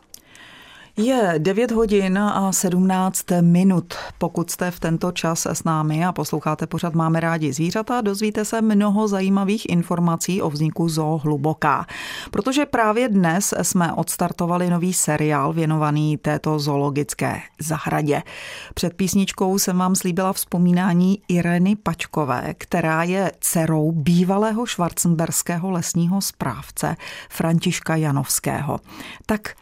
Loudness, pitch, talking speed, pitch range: -20 LUFS, 175 Hz, 115 wpm, 160-195 Hz